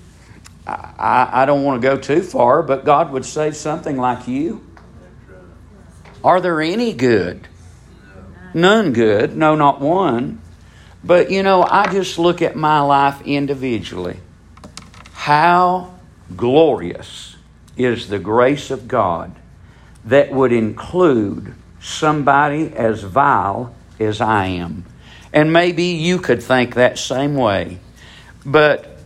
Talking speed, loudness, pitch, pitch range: 120 wpm, -16 LUFS, 130 Hz, 100-155 Hz